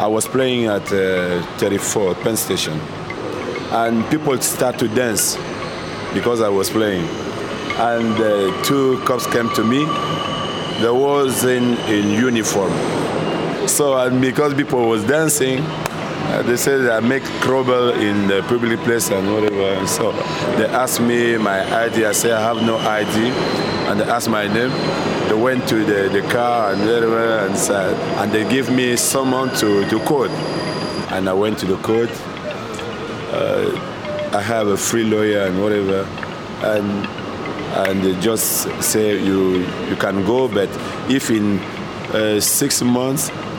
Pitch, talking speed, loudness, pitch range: 115 Hz, 155 wpm, -18 LUFS, 100-125 Hz